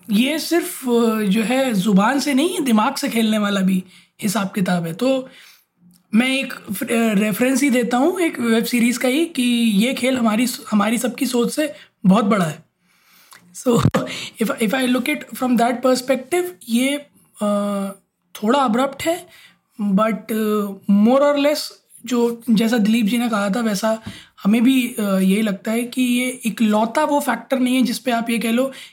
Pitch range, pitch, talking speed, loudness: 210-260 Hz, 235 Hz, 170 wpm, -19 LUFS